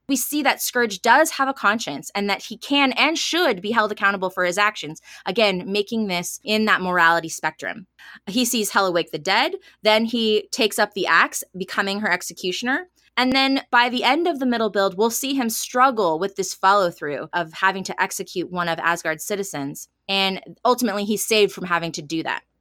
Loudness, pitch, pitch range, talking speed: -21 LUFS, 205 Hz, 185-240 Hz, 200 wpm